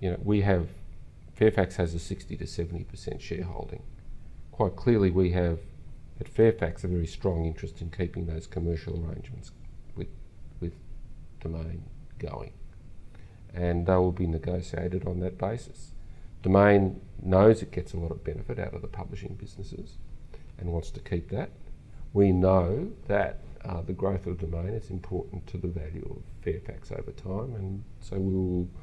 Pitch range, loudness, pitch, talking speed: 85-100 Hz, -29 LUFS, 90 Hz, 160 wpm